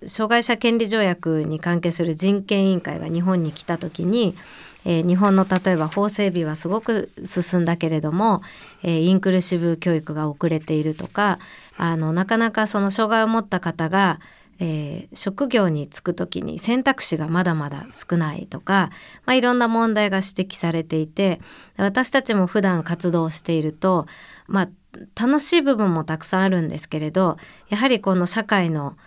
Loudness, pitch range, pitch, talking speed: -21 LUFS, 165-210 Hz, 185 Hz, 330 characters per minute